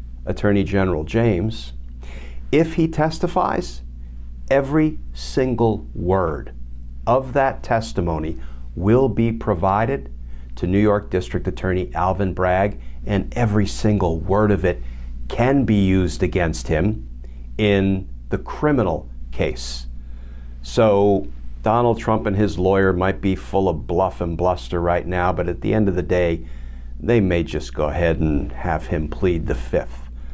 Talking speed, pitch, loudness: 140 wpm, 90 Hz, -20 LUFS